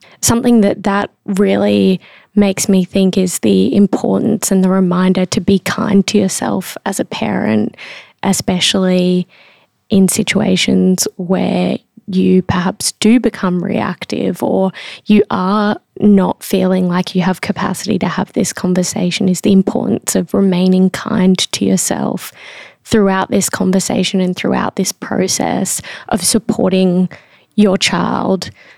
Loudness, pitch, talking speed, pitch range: -14 LUFS, 190 Hz, 130 wpm, 185-210 Hz